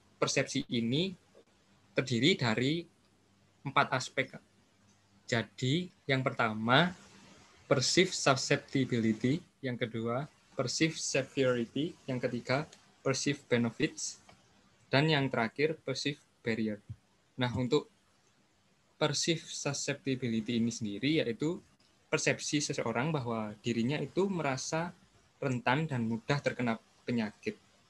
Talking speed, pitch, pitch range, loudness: 90 wpm, 130 Hz, 115-150 Hz, -32 LUFS